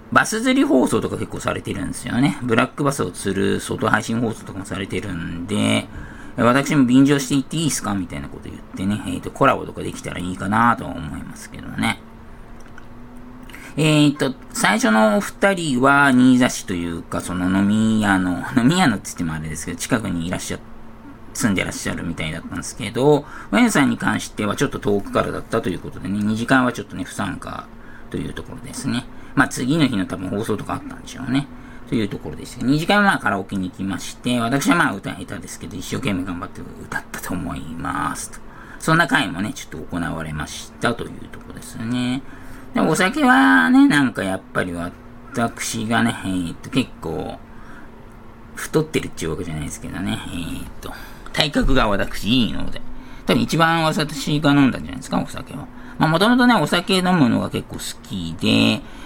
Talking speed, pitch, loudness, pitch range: 400 characters per minute, 120 Hz, -20 LUFS, 95-140 Hz